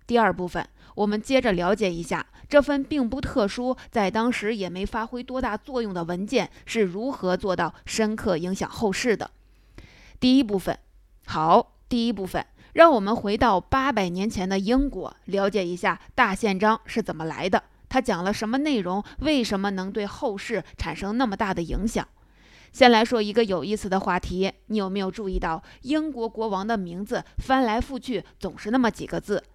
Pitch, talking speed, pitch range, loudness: 210 Hz, 275 characters per minute, 185-240 Hz, -25 LUFS